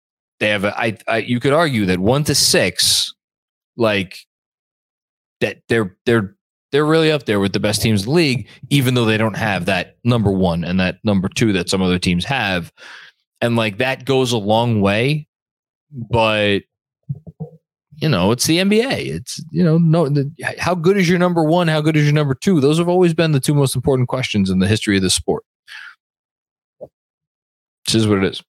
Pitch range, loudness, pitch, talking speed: 105-155 Hz, -17 LUFS, 125 Hz, 200 wpm